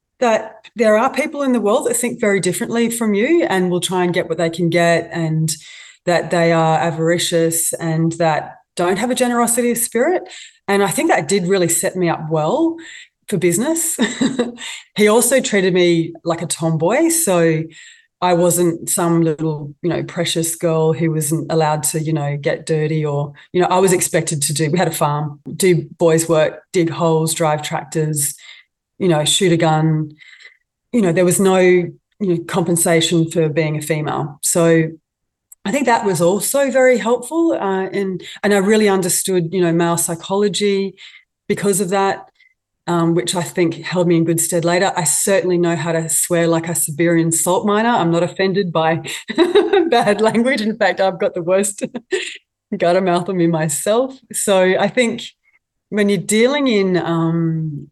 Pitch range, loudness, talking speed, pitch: 165-205 Hz, -16 LUFS, 180 wpm, 175 Hz